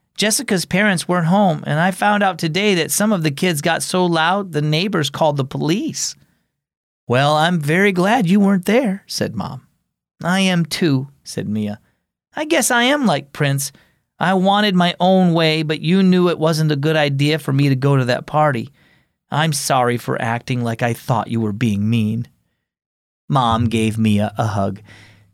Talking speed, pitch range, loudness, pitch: 185 wpm, 125-185 Hz, -17 LUFS, 155 Hz